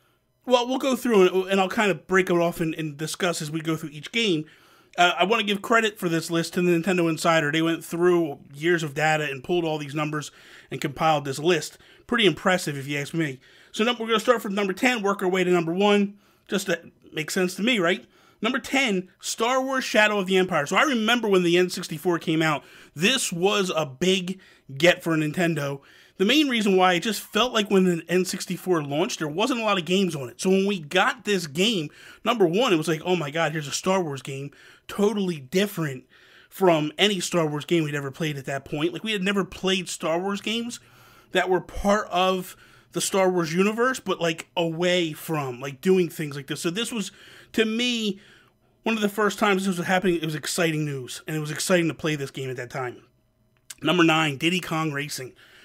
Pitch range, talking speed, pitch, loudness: 160-200 Hz, 225 wpm, 180 Hz, -24 LUFS